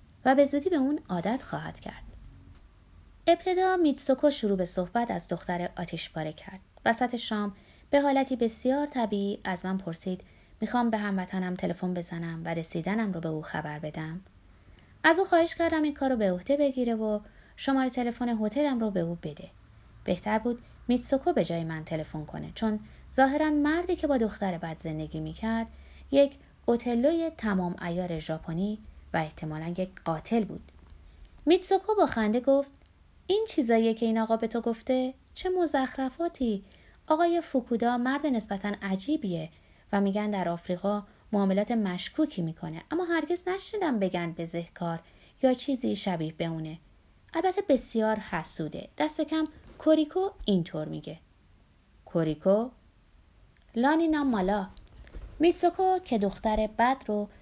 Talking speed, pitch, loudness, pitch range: 140 wpm, 220 Hz, -29 LUFS, 180-280 Hz